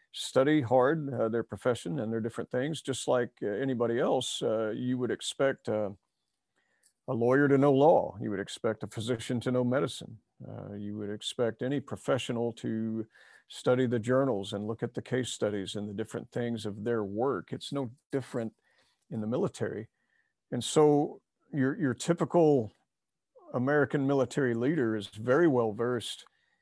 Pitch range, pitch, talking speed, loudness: 110-135 Hz, 125 Hz, 165 wpm, -30 LUFS